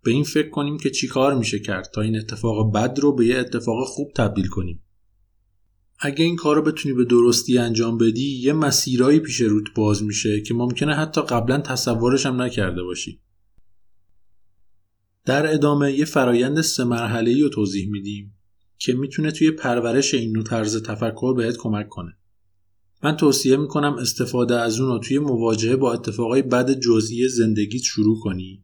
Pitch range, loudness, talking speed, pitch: 105-135 Hz, -20 LUFS, 165 wpm, 120 Hz